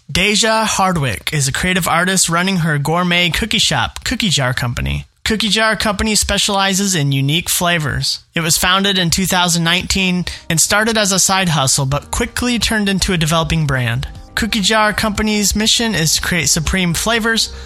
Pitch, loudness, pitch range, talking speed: 185 Hz, -14 LUFS, 160-210 Hz, 165 wpm